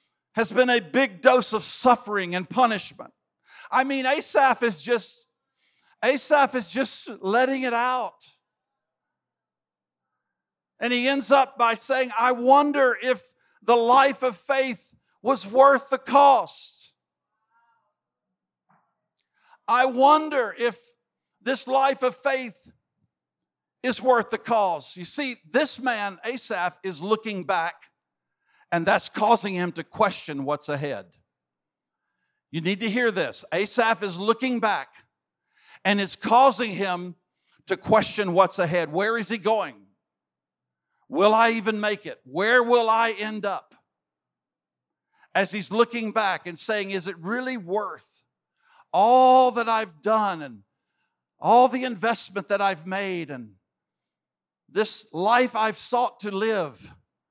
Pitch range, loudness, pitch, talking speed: 195-255 Hz, -23 LUFS, 230 Hz, 130 wpm